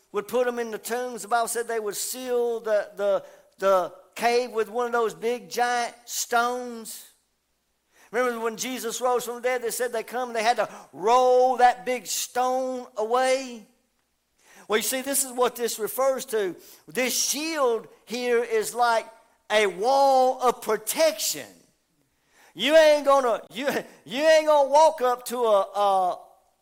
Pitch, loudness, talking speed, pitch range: 245 Hz, -24 LUFS, 165 wpm, 230-260 Hz